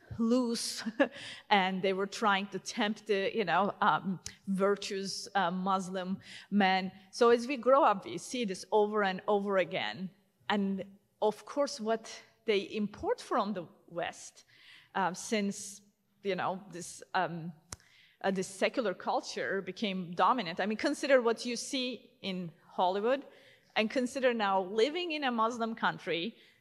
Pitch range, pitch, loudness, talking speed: 190-235 Hz, 205 Hz, -32 LUFS, 145 wpm